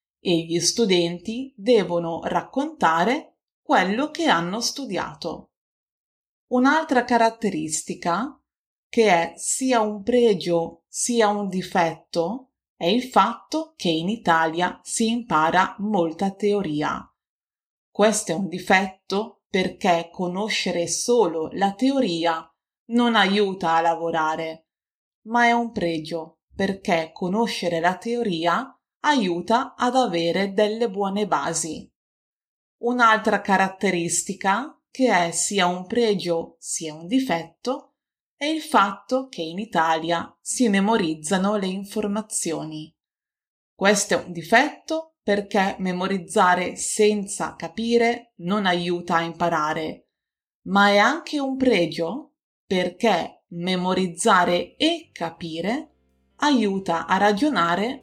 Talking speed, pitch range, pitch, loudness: 105 wpm, 170-235 Hz, 195 Hz, -22 LUFS